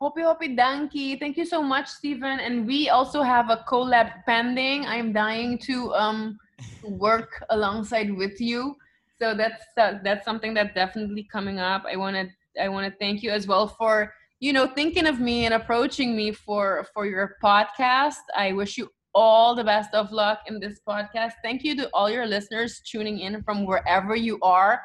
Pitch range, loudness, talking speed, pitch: 210-255 Hz, -24 LUFS, 185 wpm, 225 Hz